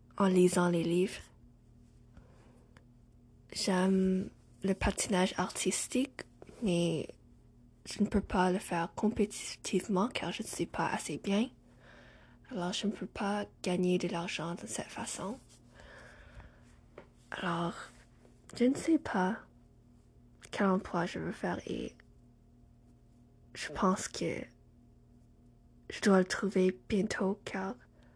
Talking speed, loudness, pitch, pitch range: 115 wpm, -33 LUFS, 180 Hz, 120-195 Hz